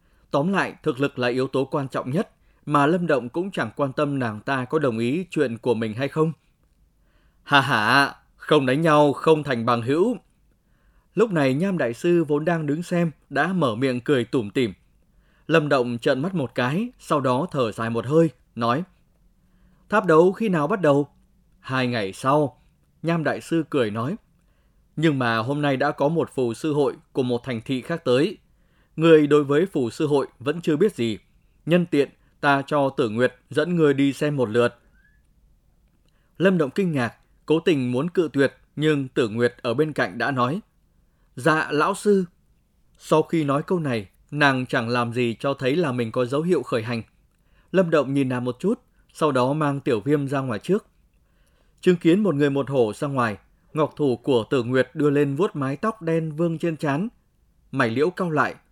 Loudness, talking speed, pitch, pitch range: -22 LUFS, 200 wpm, 145 Hz, 125-160 Hz